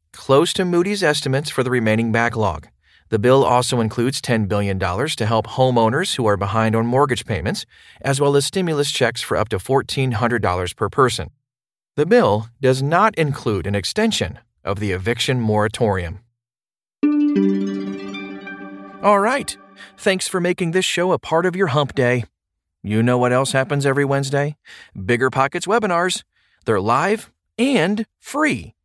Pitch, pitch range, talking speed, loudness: 125 Hz, 105-150 Hz, 150 wpm, -19 LUFS